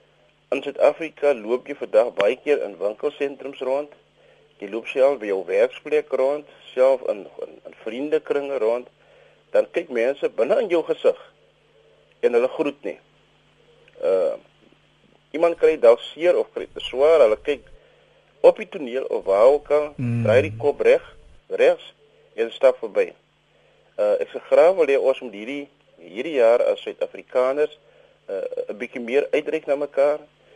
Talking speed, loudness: 165 wpm, -21 LUFS